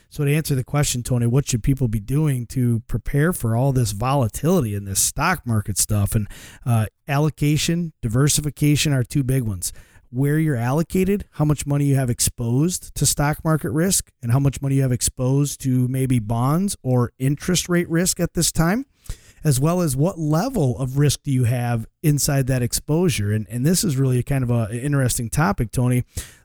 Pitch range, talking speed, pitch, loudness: 120-150 Hz, 195 wpm, 135 Hz, -21 LUFS